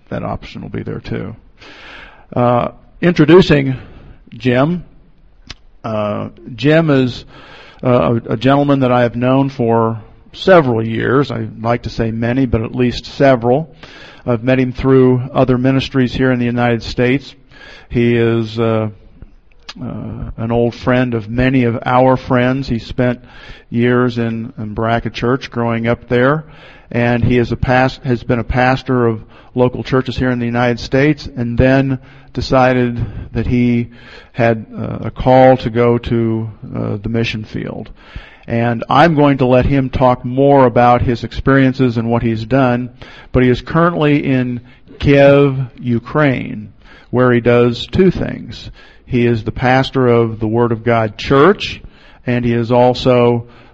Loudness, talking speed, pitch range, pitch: -14 LUFS, 155 wpm, 115-130 Hz, 125 Hz